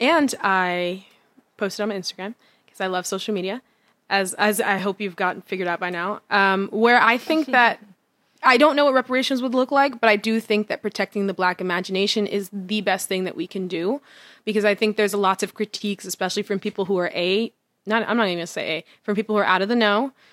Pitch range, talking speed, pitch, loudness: 190-225 Hz, 235 wpm, 205 Hz, -21 LUFS